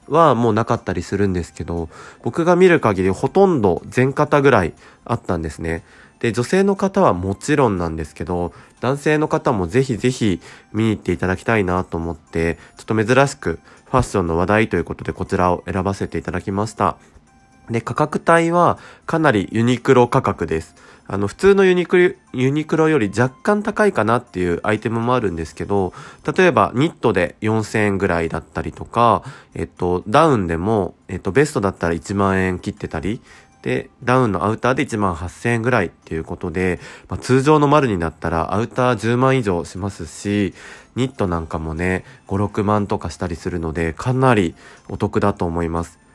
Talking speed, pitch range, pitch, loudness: 370 characters per minute, 90-130 Hz, 105 Hz, -19 LUFS